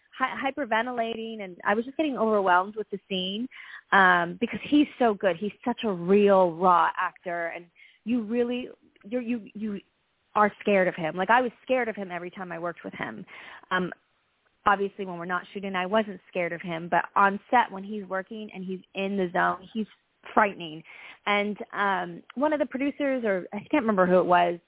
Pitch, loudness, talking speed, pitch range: 200 Hz, -26 LUFS, 195 wpm, 180-230 Hz